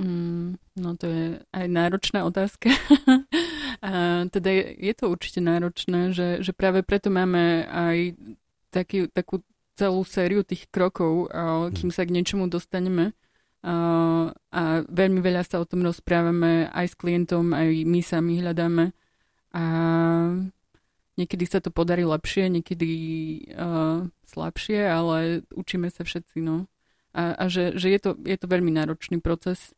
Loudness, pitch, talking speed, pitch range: -25 LUFS, 175 Hz, 140 wpm, 170-185 Hz